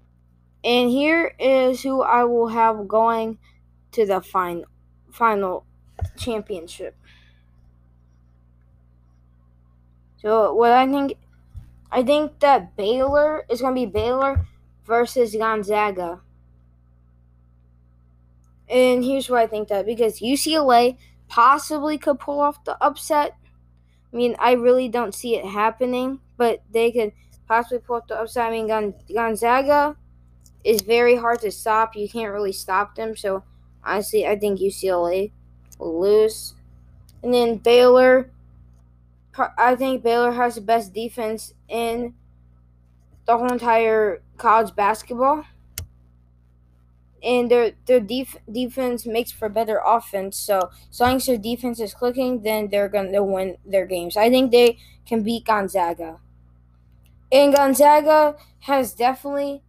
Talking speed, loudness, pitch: 130 wpm, -20 LUFS, 220 Hz